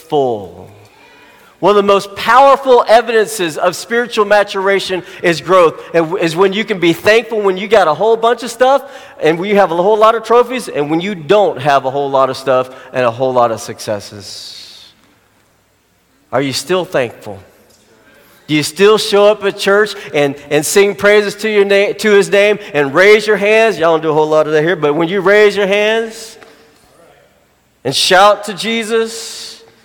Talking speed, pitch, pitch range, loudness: 190 wpm, 195 Hz, 145-215 Hz, -12 LUFS